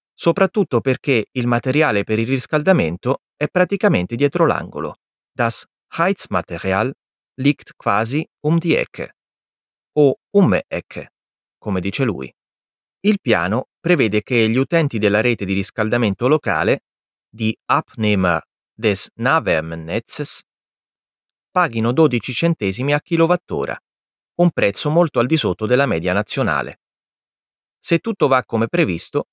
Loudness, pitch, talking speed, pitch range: -18 LUFS, 130 Hz, 120 wpm, 110-165 Hz